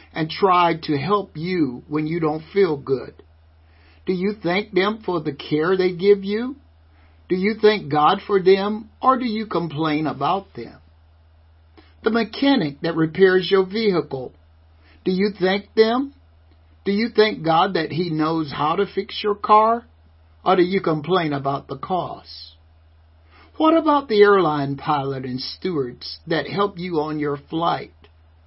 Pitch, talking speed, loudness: 160 Hz, 155 wpm, -20 LUFS